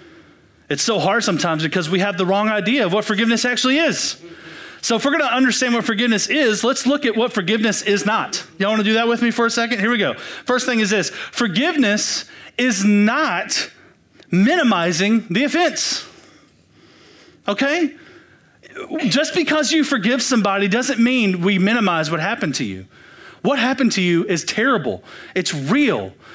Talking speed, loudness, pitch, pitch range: 170 wpm, -18 LUFS, 230 Hz, 200-255 Hz